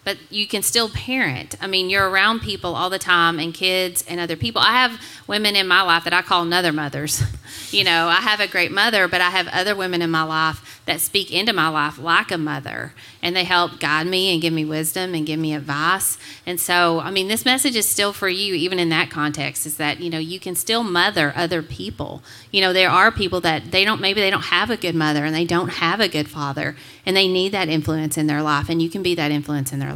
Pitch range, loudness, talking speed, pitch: 160-190 Hz, -19 LUFS, 255 wpm, 175 Hz